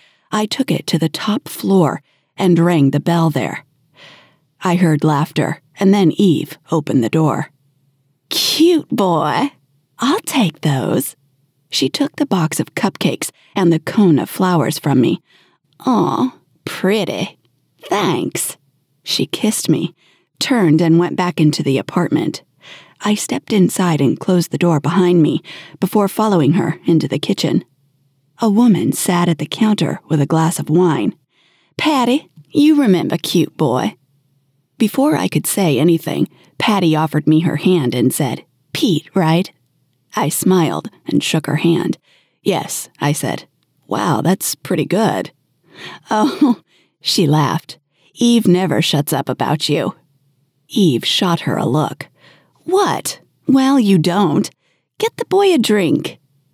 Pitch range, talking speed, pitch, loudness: 145-195 Hz, 140 wpm, 165 Hz, -16 LUFS